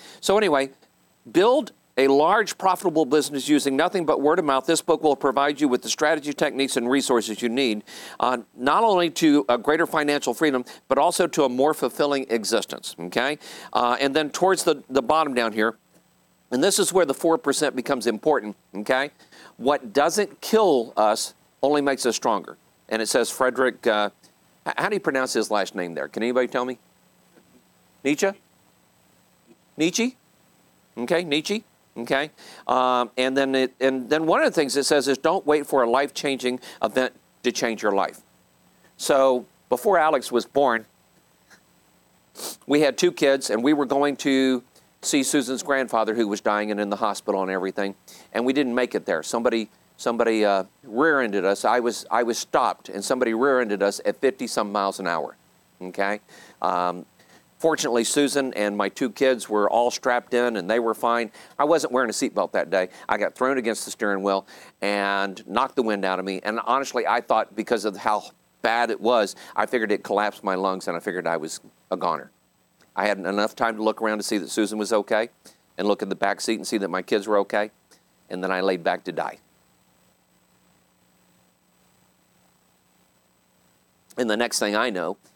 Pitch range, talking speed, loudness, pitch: 105-140 Hz, 185 wpm, -23 LUFS, 125 Hz